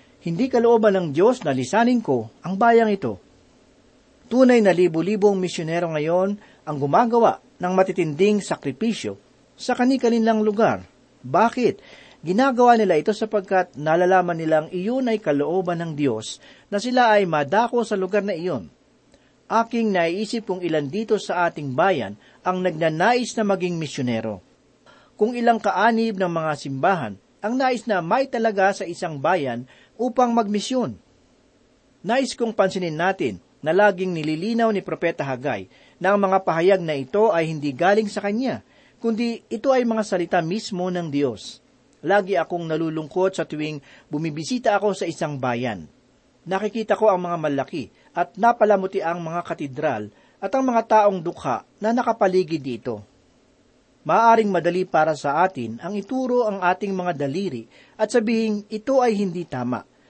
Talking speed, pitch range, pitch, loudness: 145 wpm, 160-225 Hz, 190 Hz, -21 LUFS